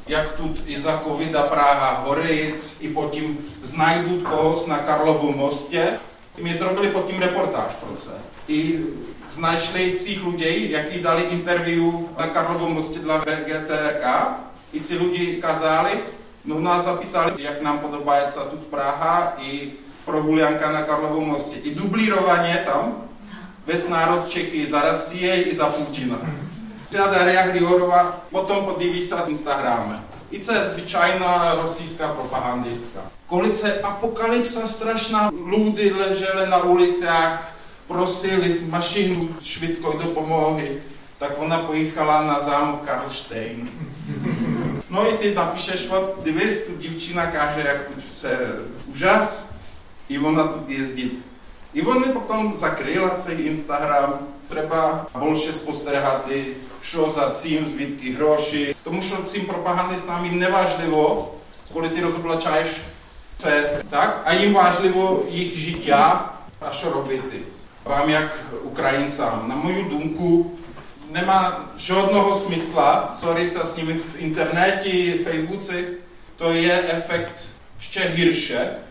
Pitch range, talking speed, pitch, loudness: 150-180 Hz, 125 wpm, 165 Hz, -21 LUFS